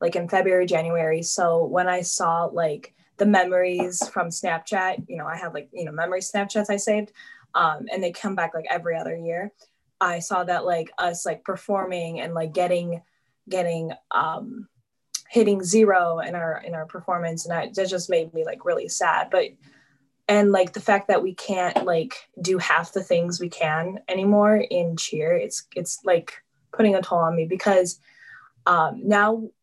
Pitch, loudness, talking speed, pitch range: 180 Hz, -23 LUFS, 180 wpm, 170-205 Hz